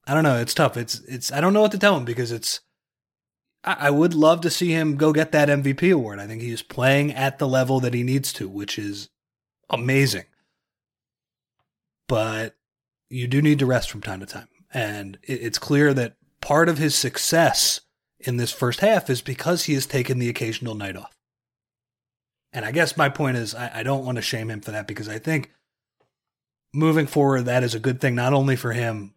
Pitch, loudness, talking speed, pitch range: 130 Hz, -22 LUFS, 215 wpm, 115-145 Hz